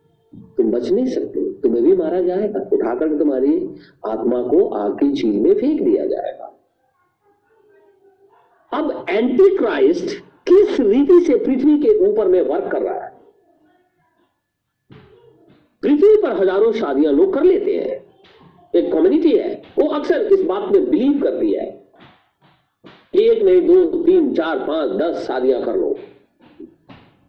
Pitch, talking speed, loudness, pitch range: 370 Hz, 135 wpm, -17 LUFS, 340-405 Hz